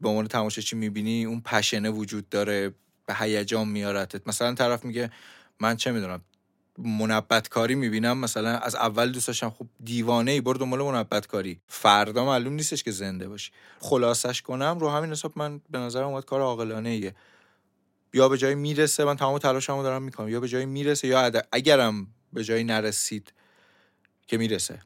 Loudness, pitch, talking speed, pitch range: -26 LUFS, 115 Hz, 170 wpm, 110-130 Hz